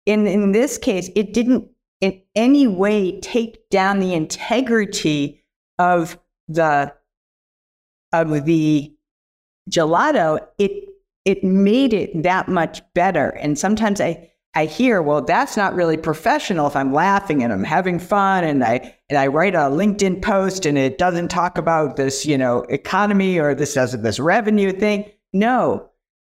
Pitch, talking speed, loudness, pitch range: 185 Hz, 150 wpm, -18 LUFS, 155-205 Hz